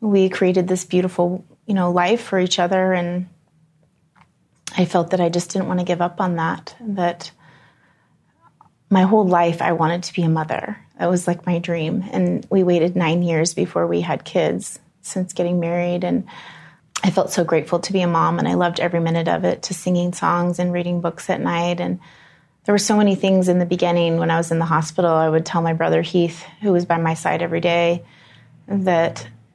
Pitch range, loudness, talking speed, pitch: 165-185 Hz, -19 LUFS, 210 wpm, 175 Hz